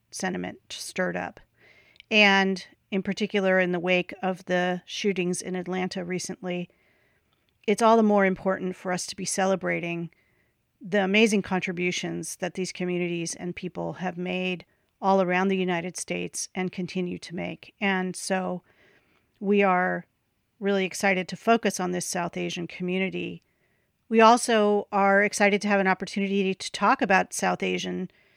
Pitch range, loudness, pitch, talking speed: 180-195 Hz, -25 LUFS, 185 Hz, 150 wpm